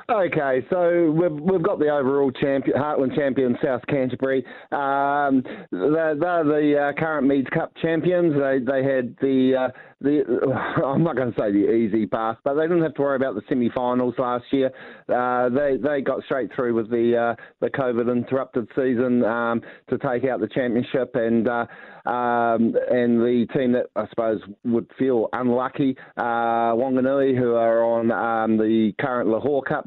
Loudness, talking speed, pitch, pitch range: -22 LUFS, 175 wpm, 130 Hz, 120-140 Hz